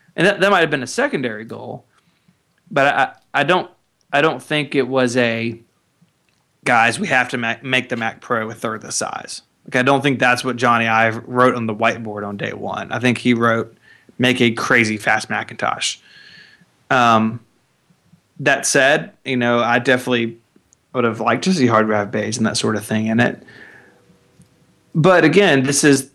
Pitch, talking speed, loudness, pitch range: 120 Hz, 195 wpm, -17 LUFS, 115-130 Hz